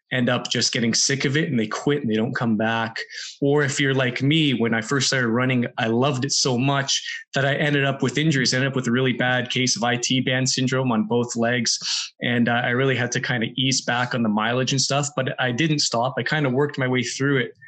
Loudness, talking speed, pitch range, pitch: -21 LUFS, 265 wpm, 120-140 Hz, 130 Hz